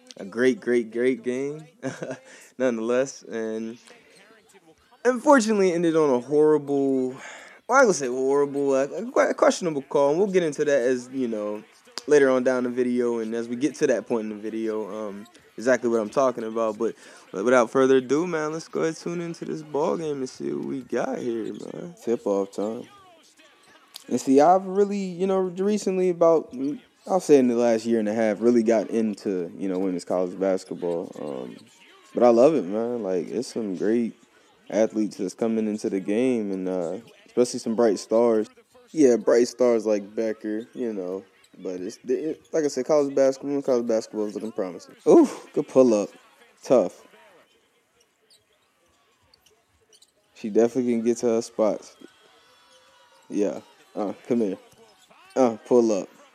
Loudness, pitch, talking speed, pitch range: -24 LUFS, 125 Hz, 170 wpm, 110-145 Hz